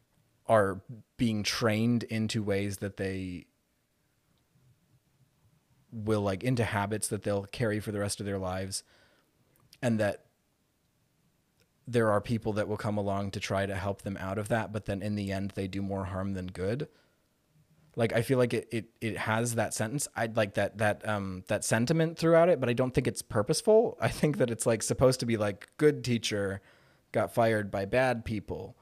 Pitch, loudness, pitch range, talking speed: 110 Hz, -30 LUFS, 100-125 Hz, 185 wpm